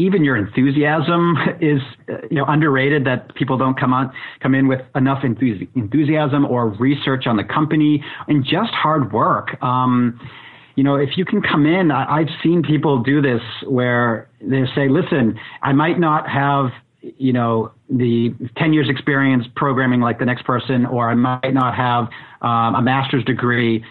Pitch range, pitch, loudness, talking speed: 125-150 Hz, 135 Hz, -17 LUFS, 170 wpm